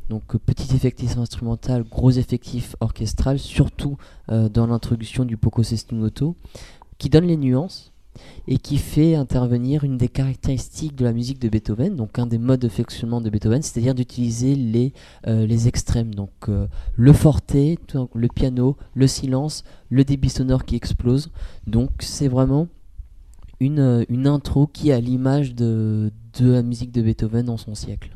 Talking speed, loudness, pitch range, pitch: 165 wpm, -21 LUFS, 115-135 Hz, 120 Hz